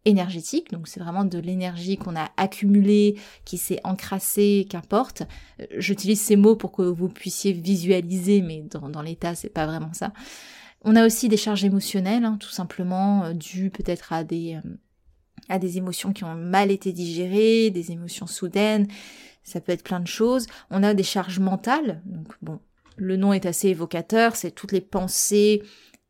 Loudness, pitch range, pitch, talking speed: -23 LUFS, 175-205 Hz, 190 Hz, 170 wpm